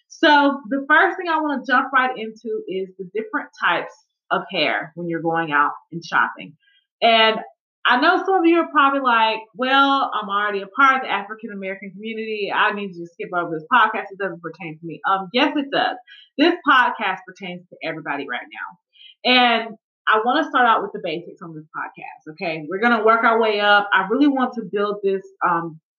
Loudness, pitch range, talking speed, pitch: -19 LUFS, 190-275 Hz, 210 wpm, 220 Hz